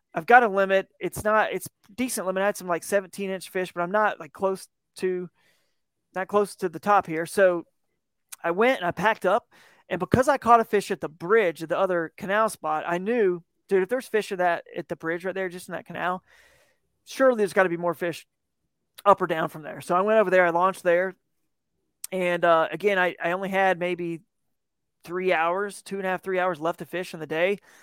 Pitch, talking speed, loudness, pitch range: 185 Hz, 230 wpm, -25 LUFS, 175-205 Hz